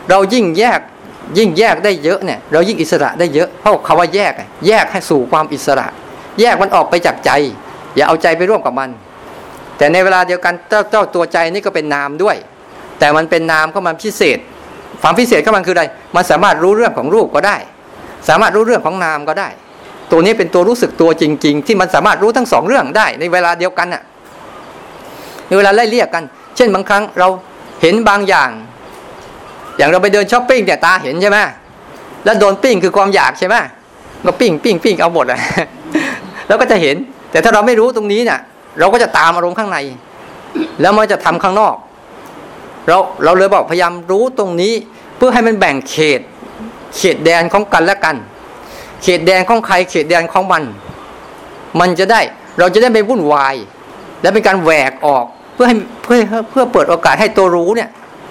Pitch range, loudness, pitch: 165-215 Hz, -11 LUFS, 190 Hz